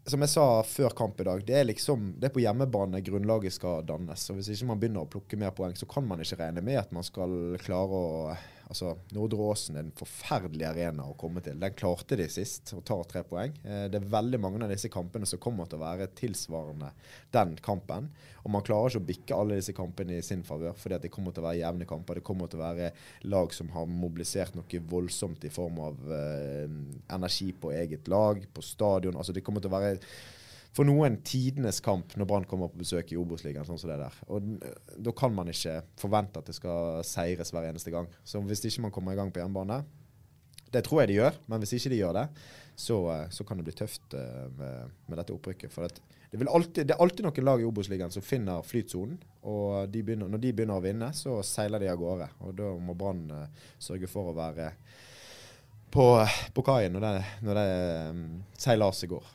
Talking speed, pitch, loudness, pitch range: 215 wpm, 95 Hz, -32 LUFS, 85-110 Hz